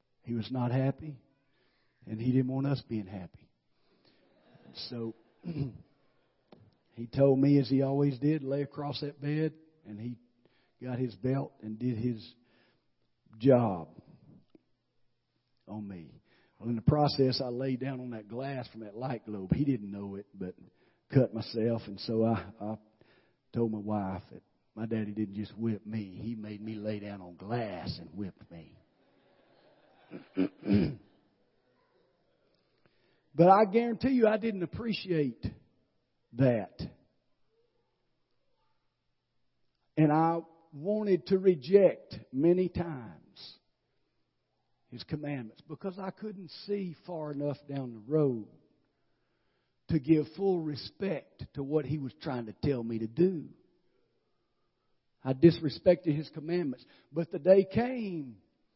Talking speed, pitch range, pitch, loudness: 130 wpm, 110-155 Hz, 130 Hz, -31 LUFS